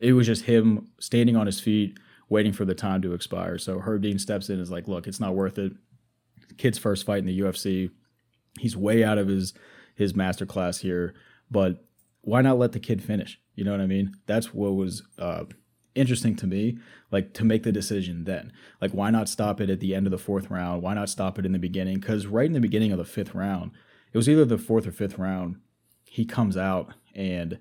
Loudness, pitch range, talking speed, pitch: -26 LUFS, 95-110 Hz, 235 wpm, 100 Hz